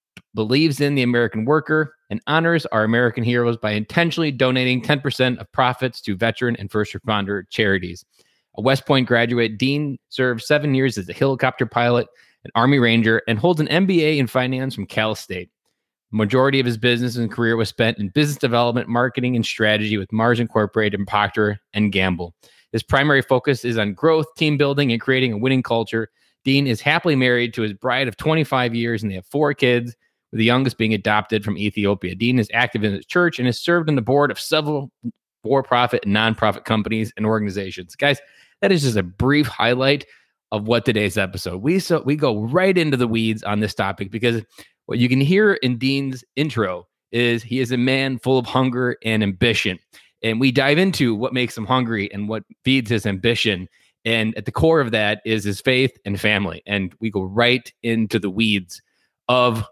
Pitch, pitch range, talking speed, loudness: 120 Hz, 110-135 Hz, 195 wpm, -19 LUFS